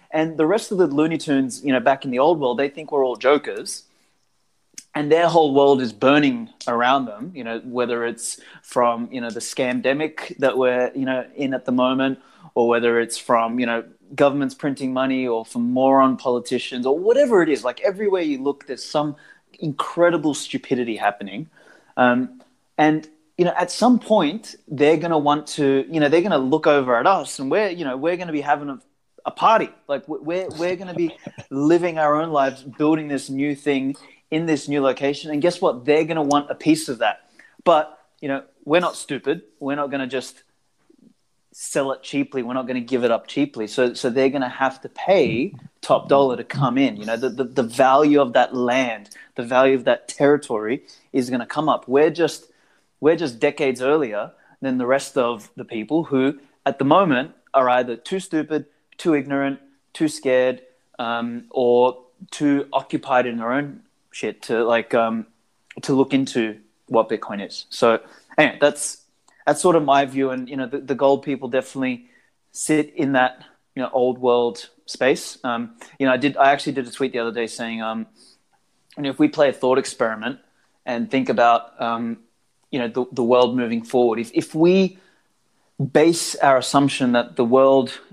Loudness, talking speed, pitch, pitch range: -20 LUFS, 200 wpm, 135 Hz, 125-150 Hz